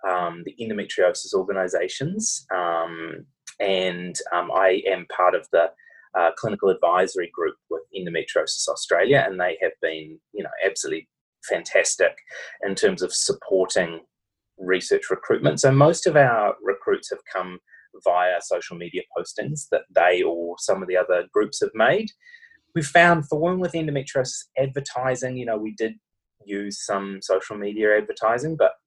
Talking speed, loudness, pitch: 150 wpm, -23 LUFS, 140 Hz